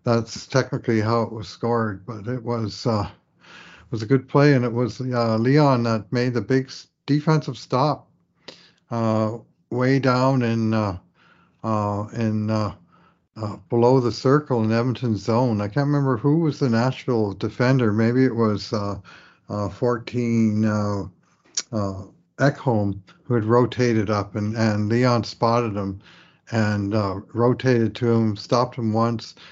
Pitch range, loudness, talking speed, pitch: 105-125 Hz, -22 LUFS, 155 wpm, 115 Hz